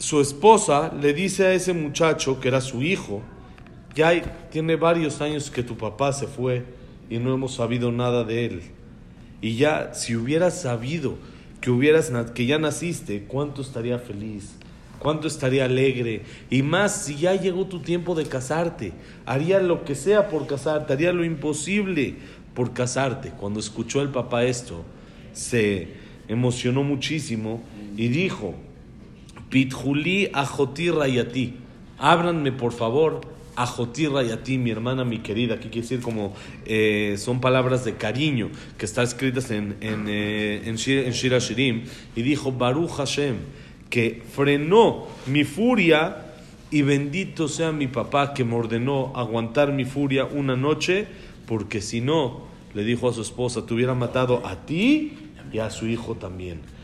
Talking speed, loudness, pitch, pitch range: 155 wpm, -23 LUFS, 130 Hz, 115-150 Hz